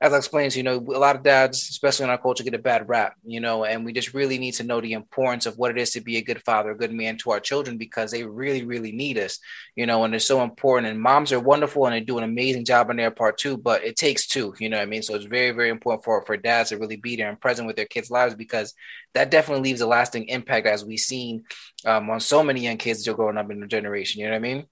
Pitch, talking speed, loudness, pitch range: 120 Hz, 300 wpm, -23 LUFS, 110-130 Hz